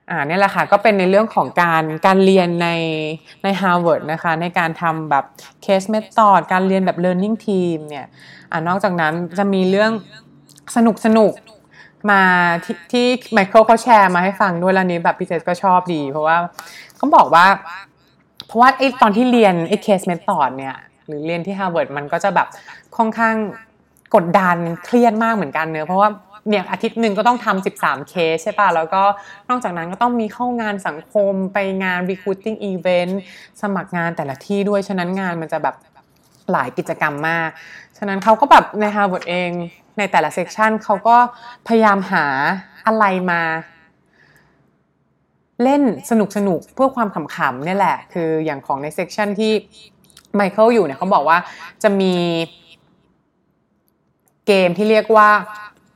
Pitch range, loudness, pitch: 170-215 Hz, -16 LUFS, 190 Hz